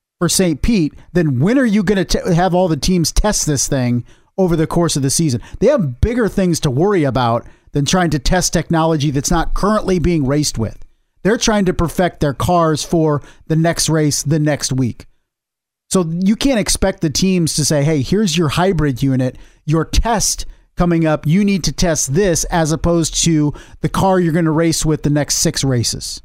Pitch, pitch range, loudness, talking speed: 160 Hz, 145-180 Hz, -16 LUFS, 205 wpm